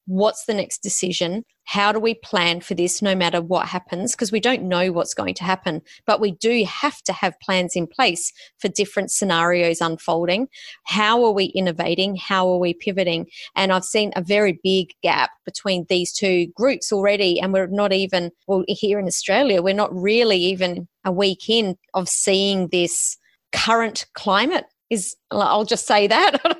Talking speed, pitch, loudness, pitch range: 180 wpm, 190 Hz, -20 LUFS, 180-210 Hz